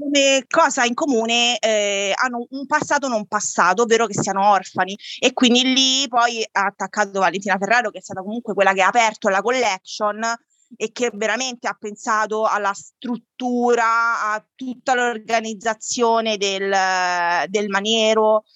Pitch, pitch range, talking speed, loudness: 220 Hz, 200-240 Hz, 145 wpm, -19 LUFS